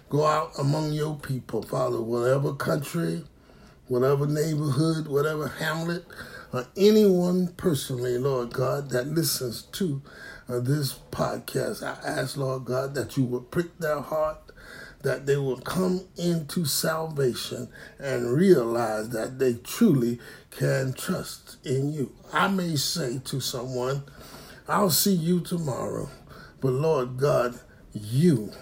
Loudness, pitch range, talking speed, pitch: -26 LUFS, 130-160 Hz, 130 wpm, 140 Hz